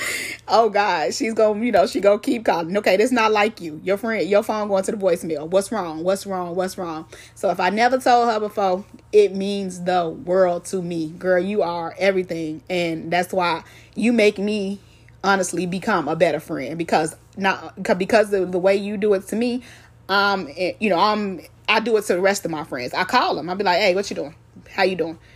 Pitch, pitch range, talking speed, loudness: 195 Hz, 175-210 Hz, 230 wpm, -21 LUFS